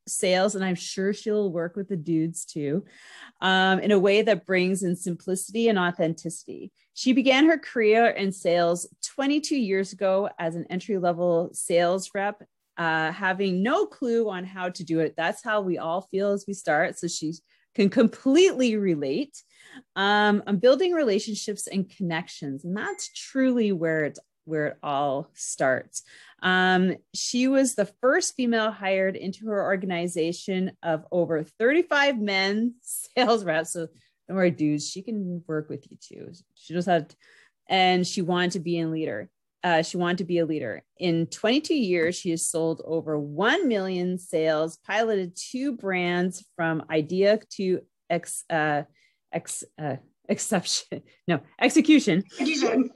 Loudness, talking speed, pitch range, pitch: -25 LUFS, 155 wpm, 170-215 Hz, 190 Hz